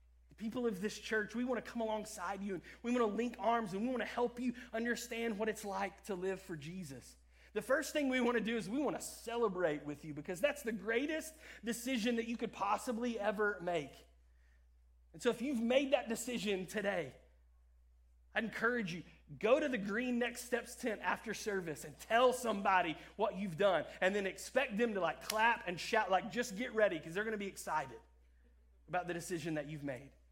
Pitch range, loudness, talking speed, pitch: 170-235 Hz, -37 LUFS, 210 wpm, 210 Hz